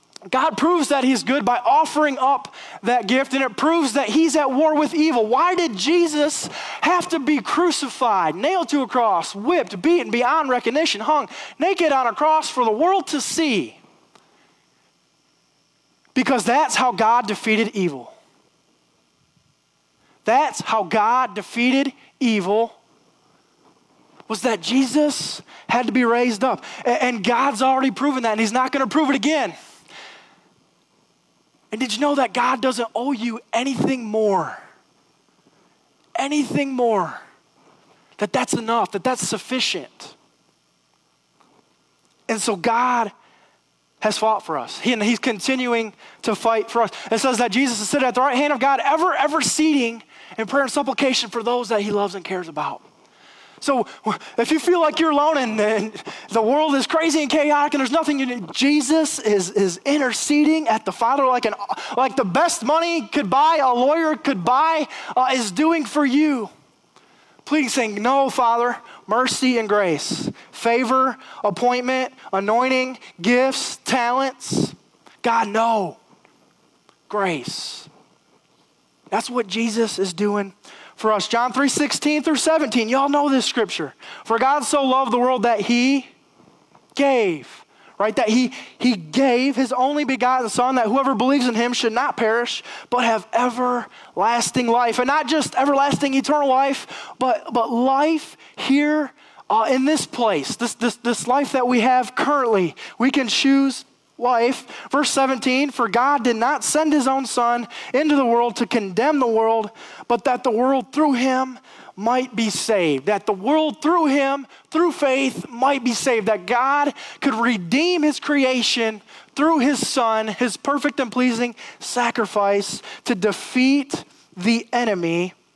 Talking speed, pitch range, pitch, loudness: 155 wpm, 230-285 Hz, 255 Hz, -20 LUFS